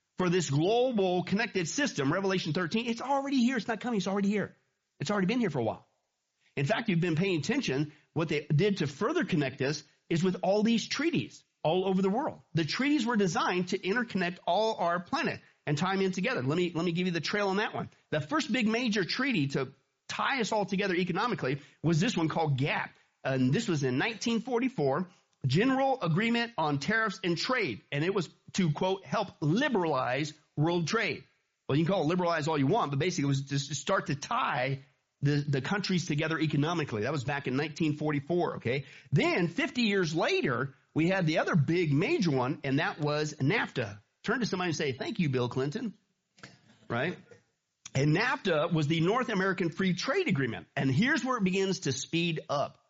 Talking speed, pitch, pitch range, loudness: 200 wpm, 175 Hz, 150-205 Hz, -30 LUFS